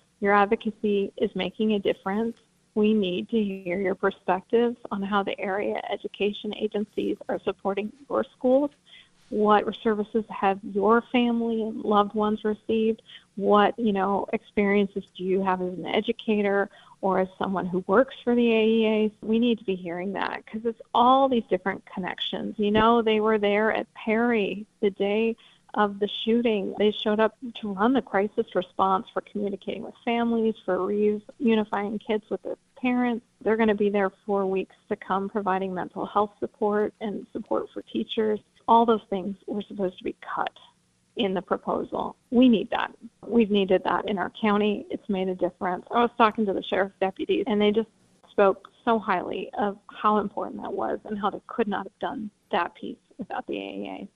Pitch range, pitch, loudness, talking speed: 195-225 Hz, 210 Hz, -26 LUFS, 180 wpm